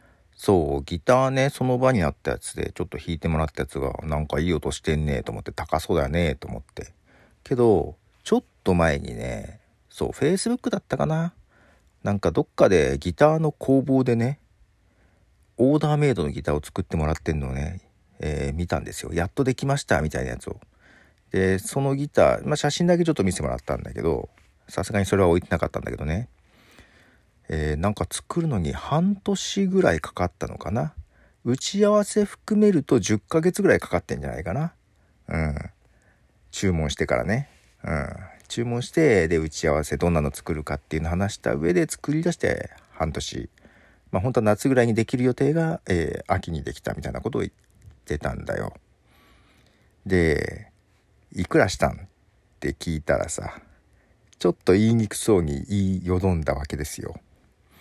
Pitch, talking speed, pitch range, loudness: 95 Hz, 365 characters per minute, 80-130 Hz, -24 LUFS